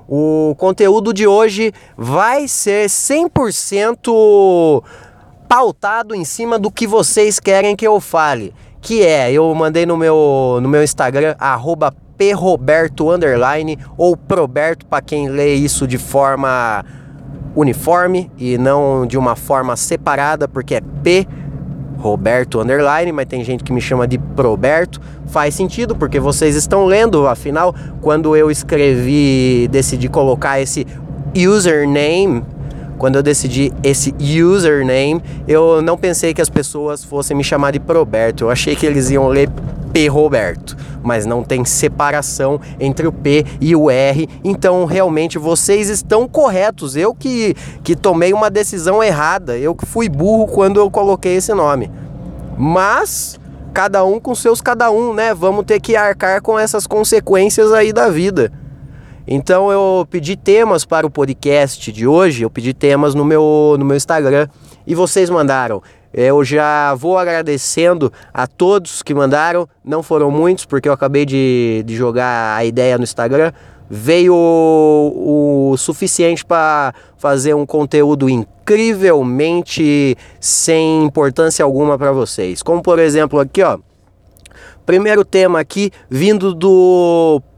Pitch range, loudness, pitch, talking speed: 140-185 Hz, -13 LUFS, 150 Hz, 140 wpm